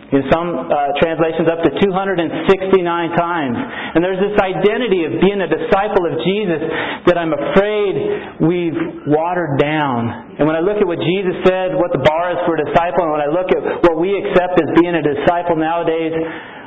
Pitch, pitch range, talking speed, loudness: 175 Hz, 160-190 Hz, 185 wpm, -16 LUFS